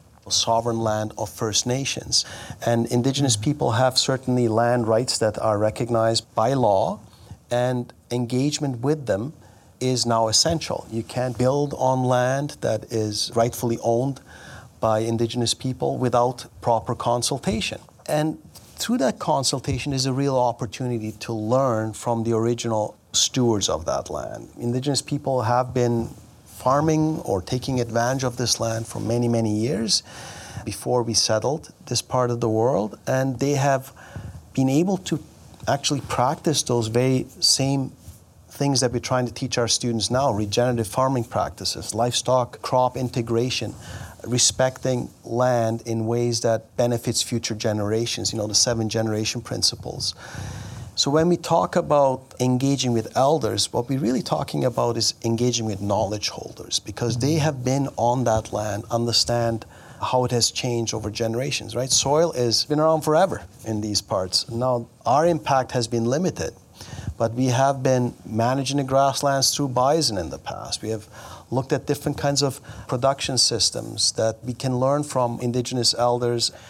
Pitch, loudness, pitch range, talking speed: 120 Hz, -22 LUFS, 115-130 Hz, 150 wpm